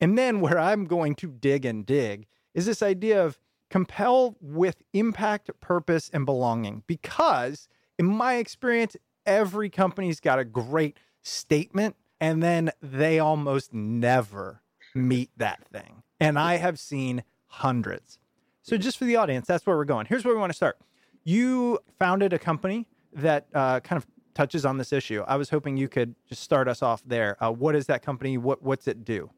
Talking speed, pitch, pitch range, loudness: 180 wpm, 155 Hz, 130-195 Hz, -26 LUFS